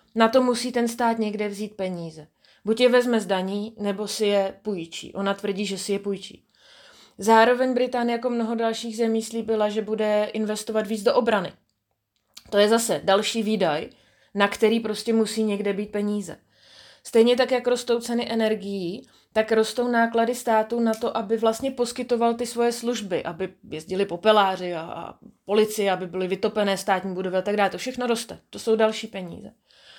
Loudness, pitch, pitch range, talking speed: -24 LUFS, 220 Hz, 200-230 Hz, 170 wpm